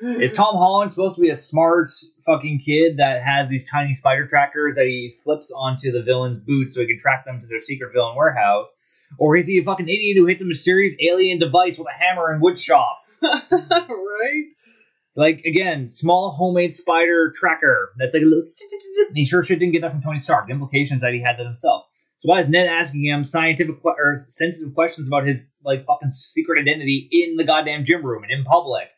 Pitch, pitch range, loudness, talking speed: 160 Hz, 140-180 Hz, -18 LUFS, 210 wpm